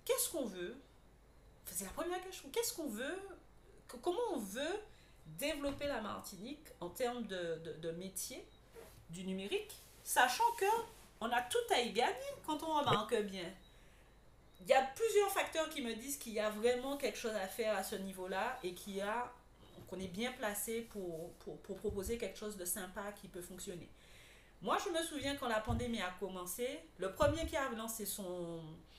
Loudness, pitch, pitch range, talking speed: -39 LUFS, 225 Hz, 190-295 Hz, 185 wpm